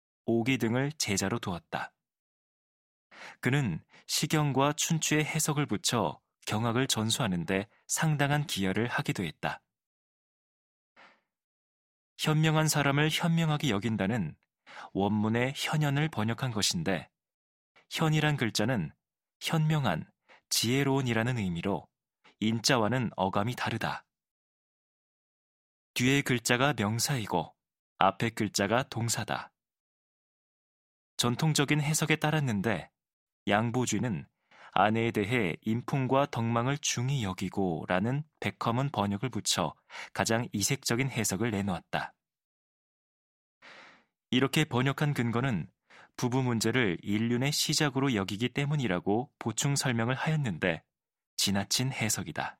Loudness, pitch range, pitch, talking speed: -30 LUFS, 105-145 Hz, 120 Hz, 245 characters per minute